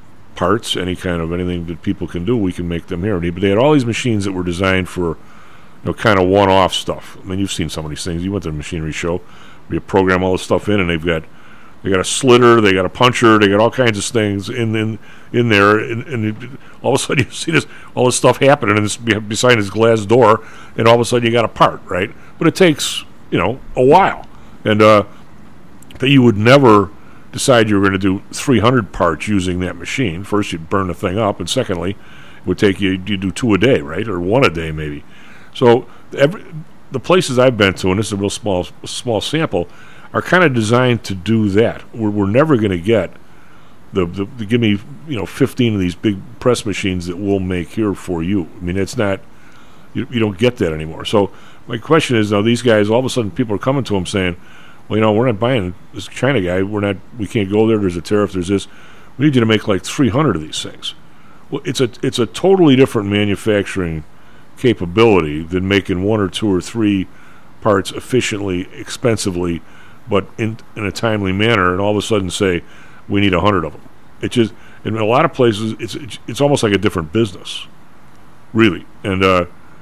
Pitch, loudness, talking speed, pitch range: 105 Hz, -15 LUFS, 230 wpm, 95-115 Hz